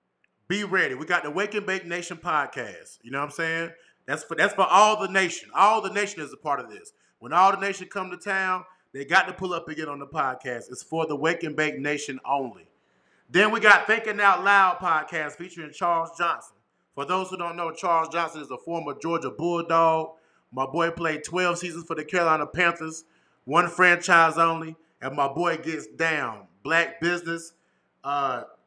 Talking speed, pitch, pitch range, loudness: 205 wpm, 165 Hz, 155-185 Hz, -24 LUFS